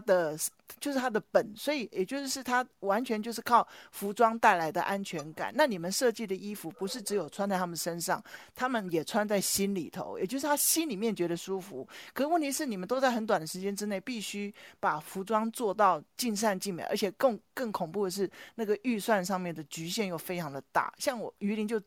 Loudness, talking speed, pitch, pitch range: -31 LUFS, 315 characters per minute, 205 Hz, 185-235 Hz